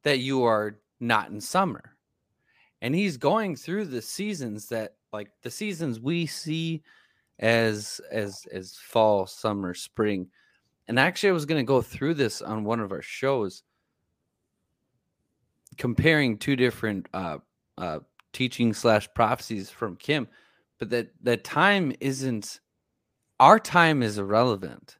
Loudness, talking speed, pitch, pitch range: -26 LUFS, 135 wpm, 120 Hz, 110-155 Hz